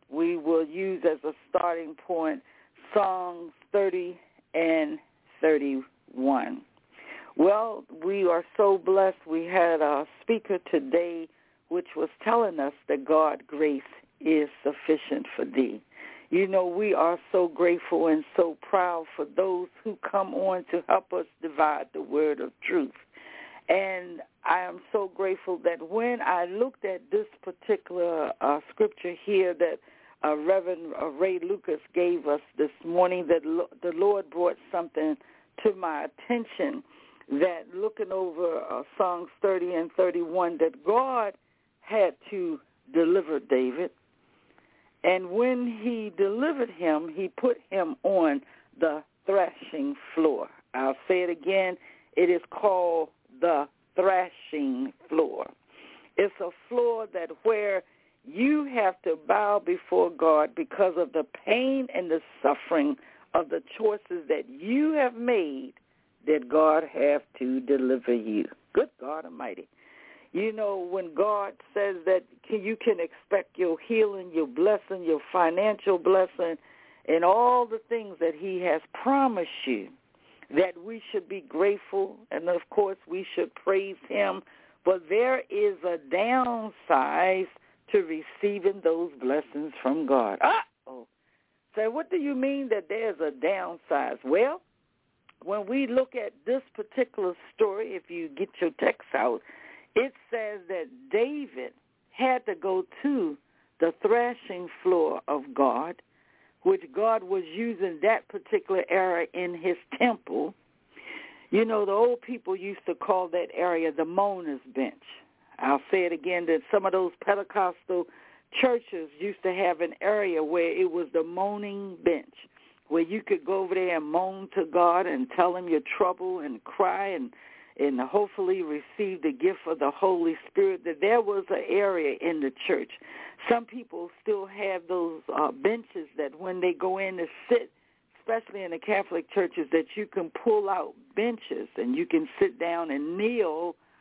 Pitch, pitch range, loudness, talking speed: 195 Hz, 170-255 Hz, -28 LUFS, 150 wpm